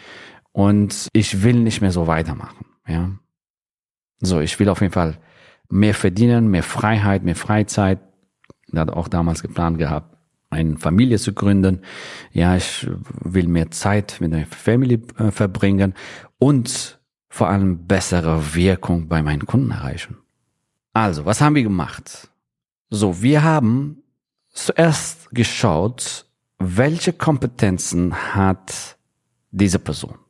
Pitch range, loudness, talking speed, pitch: 85-110 Hz, -19 LUFS, 125 wpm, 95 Hz